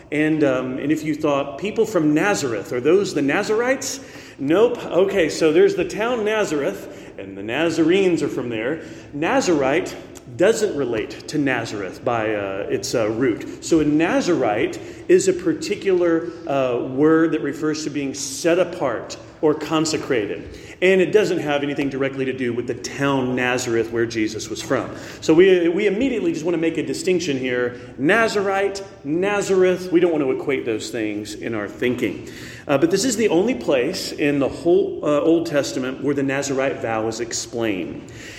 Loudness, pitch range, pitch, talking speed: -20 LUFS, 135-215 Hz, 155 Hz, 170 wpm